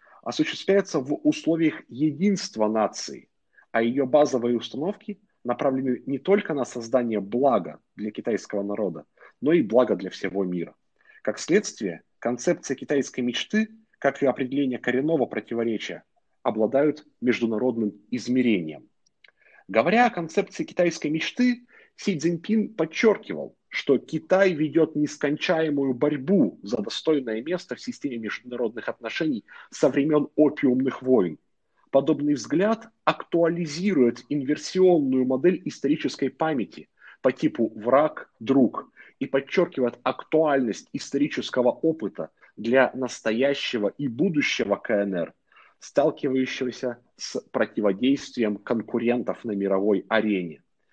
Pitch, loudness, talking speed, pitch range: 135 Hz, -25 LUFS, 105 wpm, 120-165 Hz